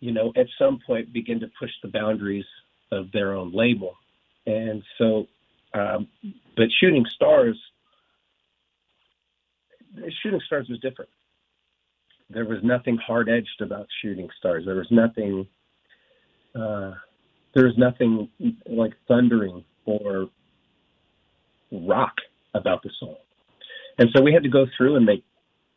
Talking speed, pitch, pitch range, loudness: 130 wpm, 115 Hz, 105-135 Hz, -23 LUFS